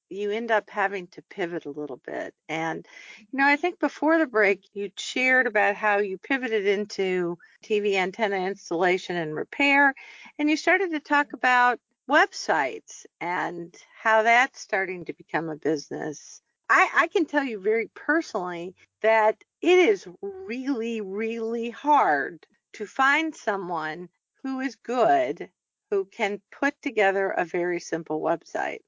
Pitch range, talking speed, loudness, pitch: 190-280 Hz, 150 wpm, -24 LUFS, 220 Hz